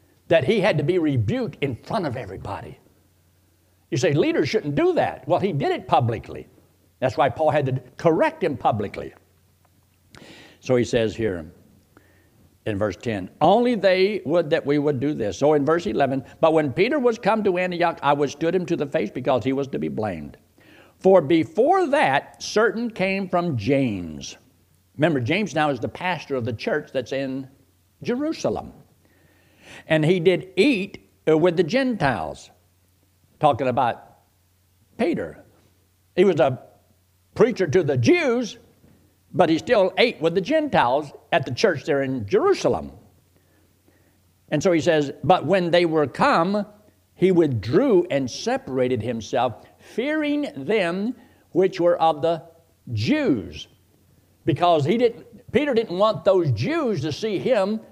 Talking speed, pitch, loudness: 155 wpm, 145 Hz, -22 LUFS